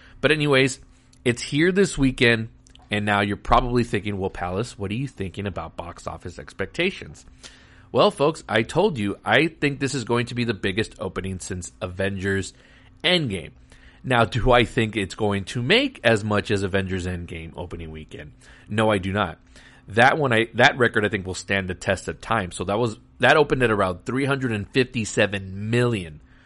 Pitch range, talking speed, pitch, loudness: 95-120 Hz, 180 wpm, 105 Hz, -22 LUFS